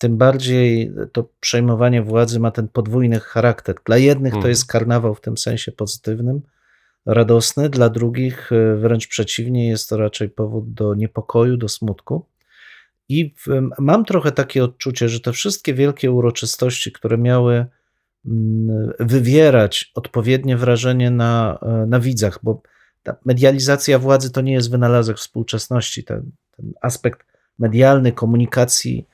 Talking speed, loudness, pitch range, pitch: 130 wpm, -17 LUFS, 115-130 Hz, 120 Hz